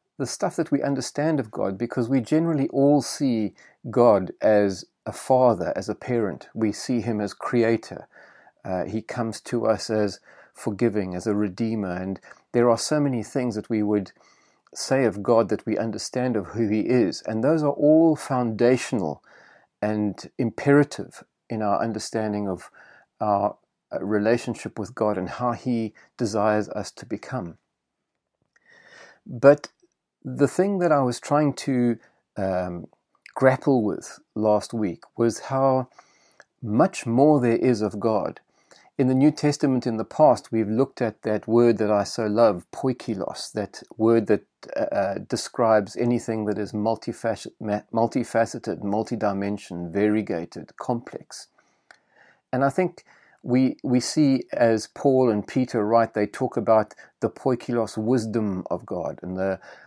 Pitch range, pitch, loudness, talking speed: 105-130 Hz, 115 Hz, -24 LUFS, 145 wpm